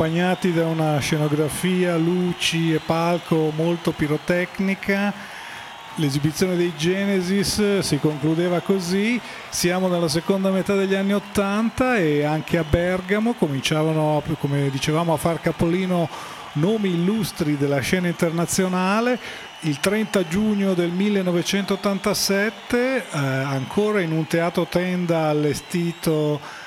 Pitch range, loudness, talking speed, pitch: 160-195 Hz, -21 LUFS, 110 wpm, 175 Hz